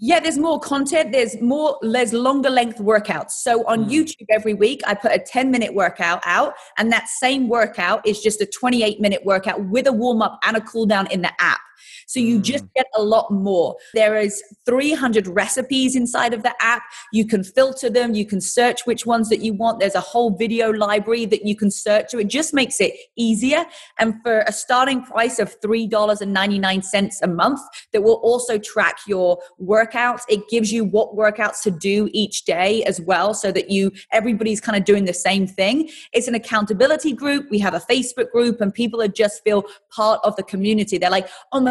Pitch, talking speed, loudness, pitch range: 220 Hz, 210 wpm, -19 LUFS, 205-245 Hz